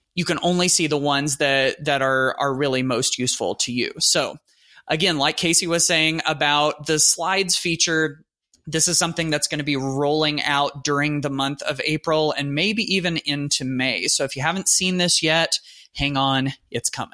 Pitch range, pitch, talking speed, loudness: 140-170 Hz, 150 Hz, 195 wpm, -20 LUFS